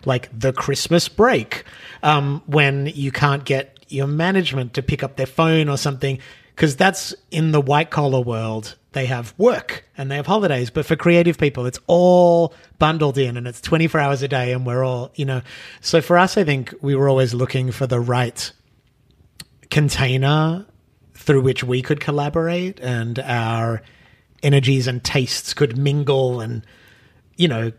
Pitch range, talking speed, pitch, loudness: 125-150 Hz, 170 wpm, 140 Hz, -19 LUFS